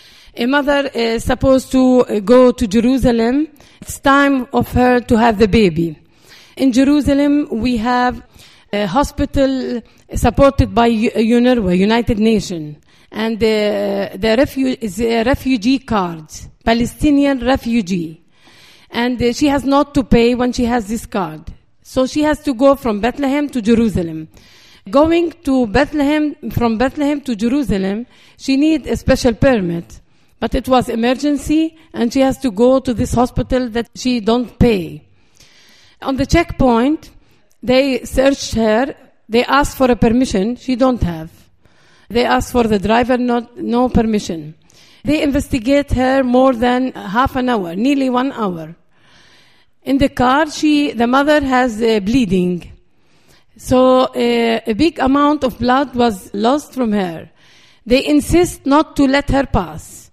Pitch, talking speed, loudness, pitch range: 250 Hz, 150 wpm, -15 LUFS, 230-275 Hz